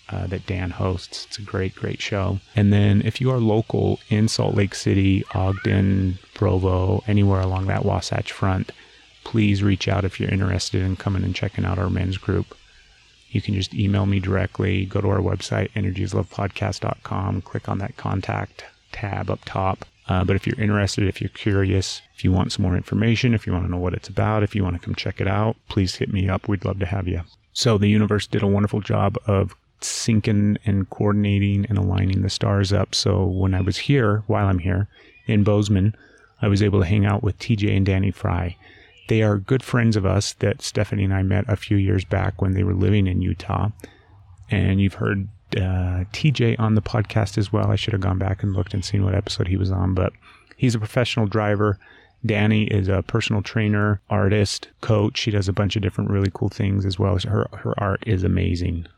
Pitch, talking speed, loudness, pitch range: 100 Hz, 215 wpm, -22 LUFS, 95-105 Hz